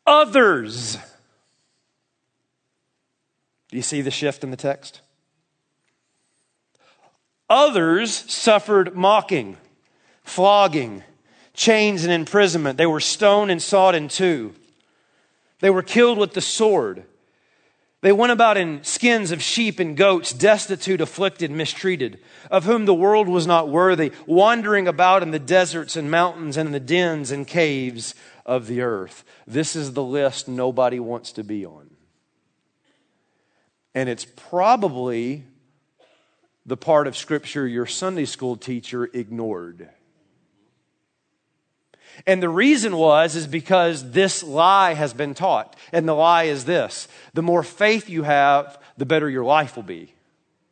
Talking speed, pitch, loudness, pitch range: 135 wpm, 165 Hz, -19 LUFS, 140-190 Hz